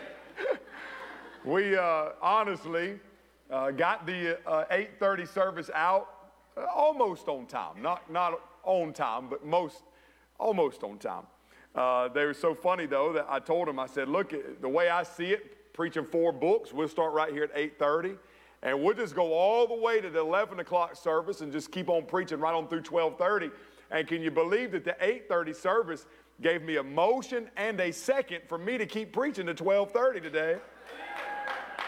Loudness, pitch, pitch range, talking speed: -30 LUFS, 175 Hz, 165-210 Hz, 175 wpm